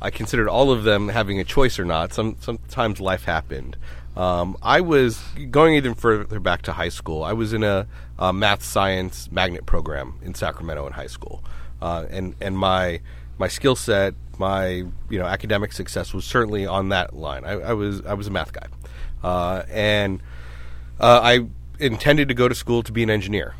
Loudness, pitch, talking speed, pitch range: -21 LUFS, 95 Hz, 195 wpm, 80-105 Hz